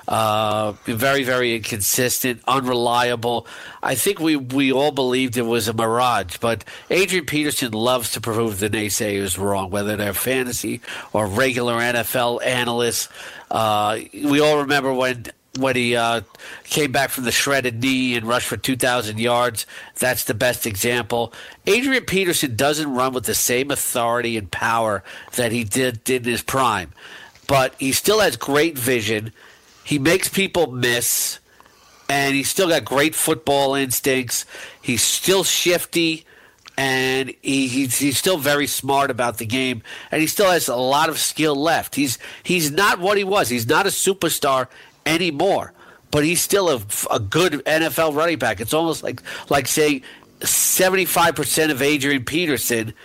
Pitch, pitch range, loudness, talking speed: 130 Hz, 120-145 Hz, -19 LUFS, 160 wpm